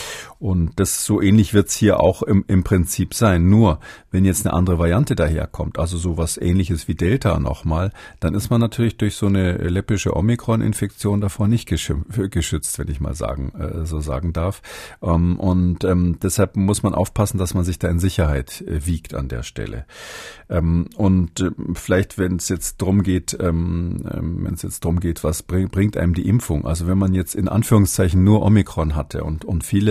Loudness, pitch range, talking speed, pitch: -20 LUFS, 85-100 Hz, 180 wpm, 90 Hz